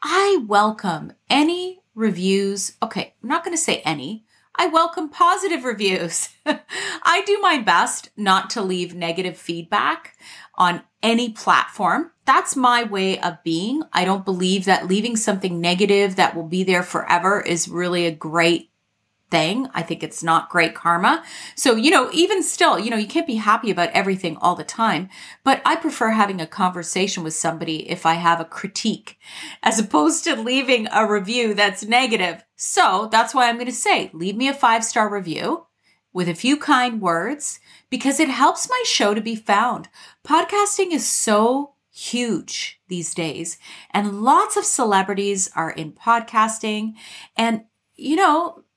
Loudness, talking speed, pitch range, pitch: -20 LUFS, 165 wpm, 180-275 Hz, 215 Hz